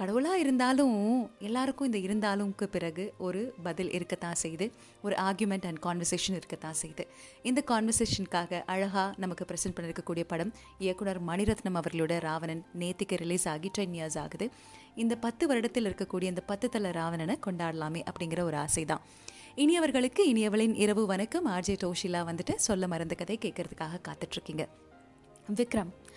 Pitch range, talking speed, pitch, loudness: 170-220 Hz, 135 wpm, 190 Hz, -32 LUFS